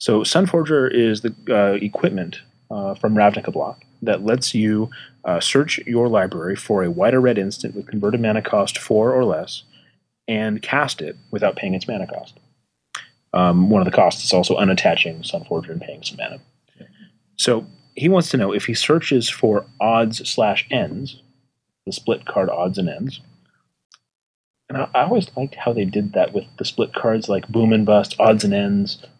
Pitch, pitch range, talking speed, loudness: 115 Hz, 105-130 Hz, 185 wpm, -19 LUFS